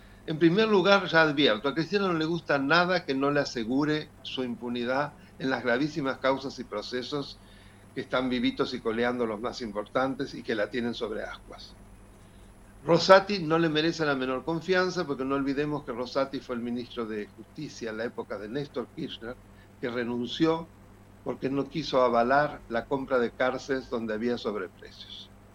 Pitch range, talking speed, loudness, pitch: 110-145 Hz, 170 wpm, -28 LUFS, 130 Hz